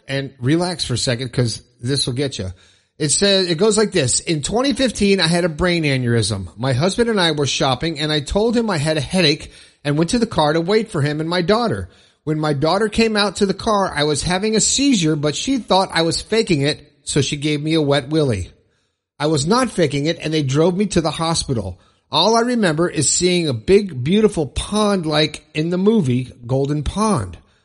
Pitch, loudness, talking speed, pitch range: 155 Hz, -18 LUFS, 225 wpm, 135-195 Hz